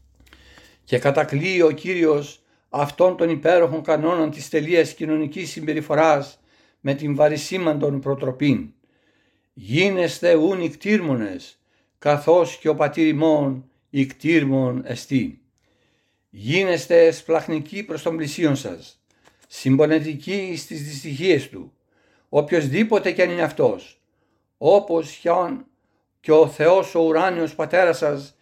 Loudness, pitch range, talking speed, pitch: -20 LUFS, 140-170 Hz, 105 wpm, 155 Hz